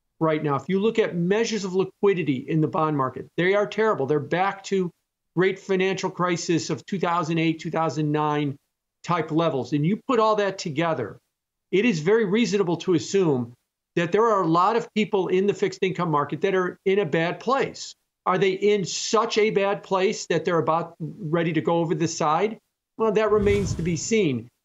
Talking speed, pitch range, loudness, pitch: 190 wpm, 160-200 Hz, -23 LUFS, 180 Hz